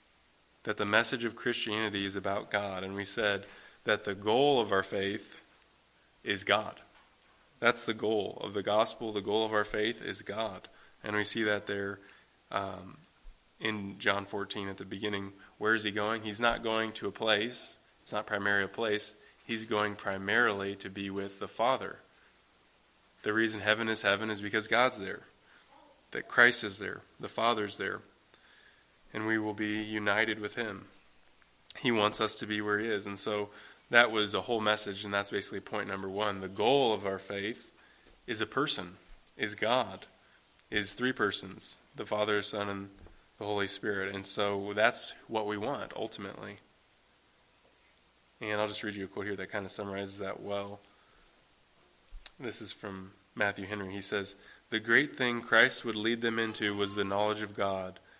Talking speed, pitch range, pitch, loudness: 175 wpm, 100-110 Hz, 105 Hz, -31 LUFS